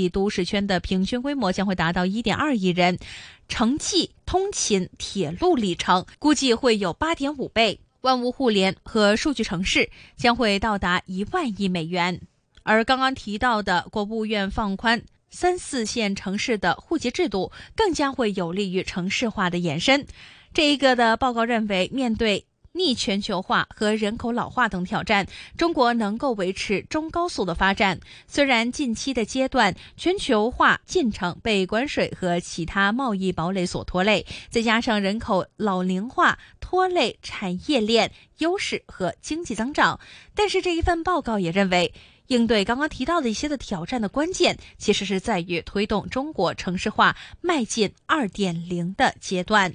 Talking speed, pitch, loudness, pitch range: 250 characters per minute, 220 Hz, -23 LUFS, 190-265 Hz